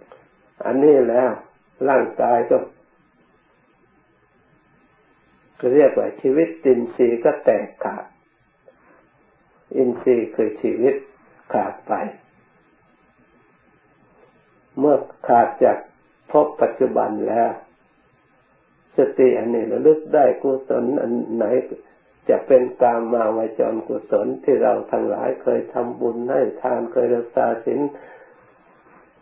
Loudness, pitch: -19 LUFS, 135 Hz